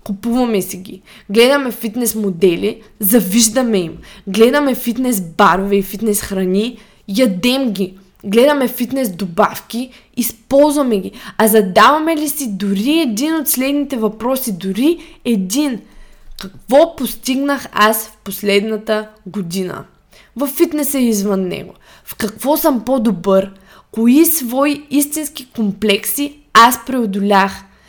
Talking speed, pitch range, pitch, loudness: 115 wpm, 200-265 Hz, 225 Hz, -15 LUFS